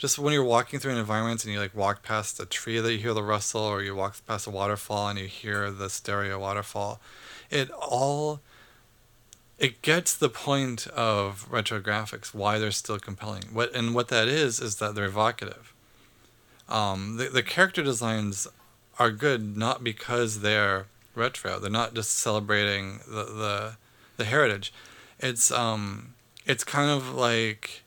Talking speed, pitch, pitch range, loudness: 170 wpm, 110 Hz, 105-120 Hz, -27 LUFS